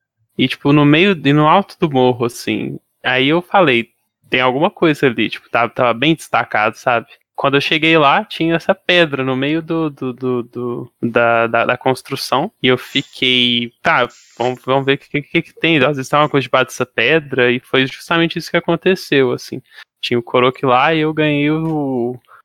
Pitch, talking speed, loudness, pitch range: 140 Hz, 195 wpm, -15 LUFS, 125-160 Hz